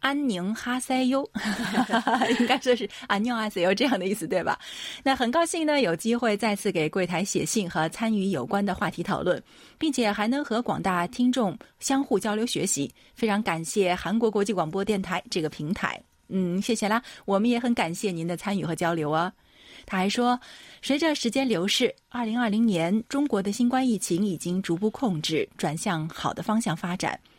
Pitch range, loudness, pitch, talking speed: 185-240 Hz, -26 LUFS, 210 Hz, 285 characters per minute